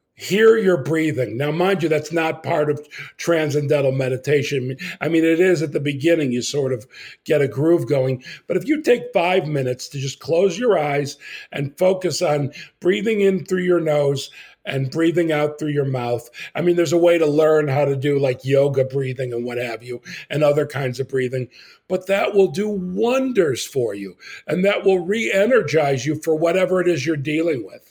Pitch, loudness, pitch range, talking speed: 150 Hz, -20 LUFS, 135-180 Hz, 200 wpm